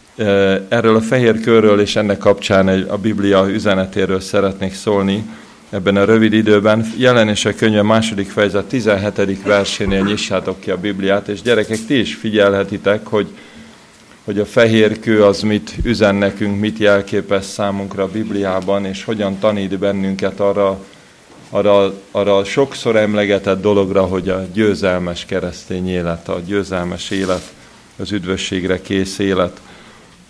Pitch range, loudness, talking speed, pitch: 95-105 Hz, -15 LUFS, 140 wpm, 100 Hz